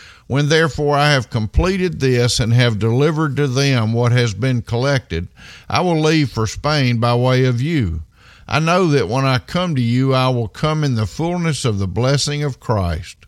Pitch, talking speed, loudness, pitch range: 130 Hz, 195 wpm, -17 LUFS, 115-145 Hz